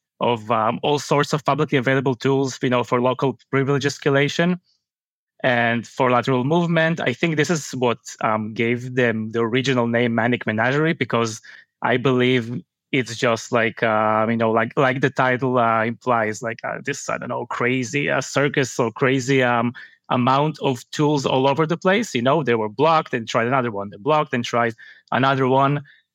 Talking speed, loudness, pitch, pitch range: 185 wpm, -20 LUFS, 130 Hz, 115-140 Hz